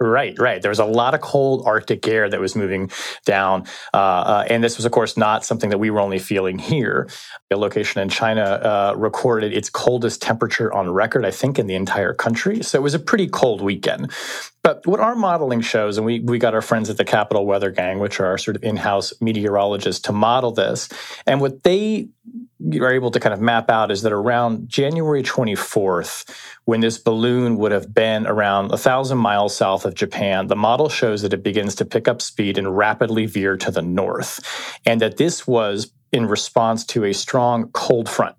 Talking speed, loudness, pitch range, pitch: 210 wpm, -19 LUFS, 100-120 Hz, 110 Hz